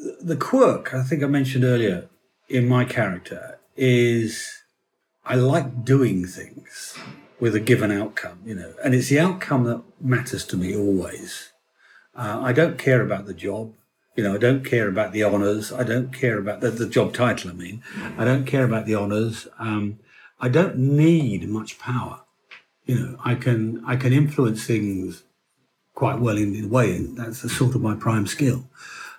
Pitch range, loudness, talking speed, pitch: 110-130 Hz, -22 LUFS, 185 wpm, 120 Hz